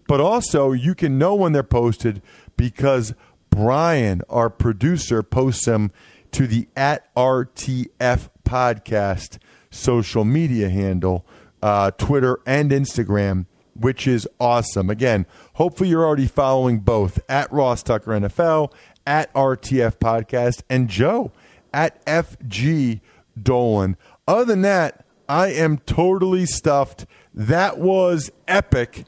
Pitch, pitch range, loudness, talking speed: 125 Hz, 110-145 Hz, -20 LUFS, 120 wpm